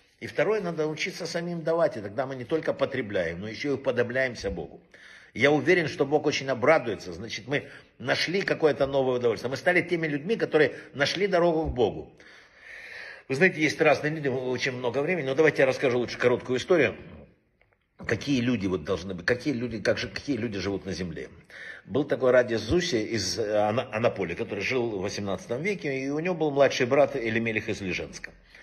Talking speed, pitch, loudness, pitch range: 180 wpm, 135 Hz, -26 LUFS, 120-160 Hz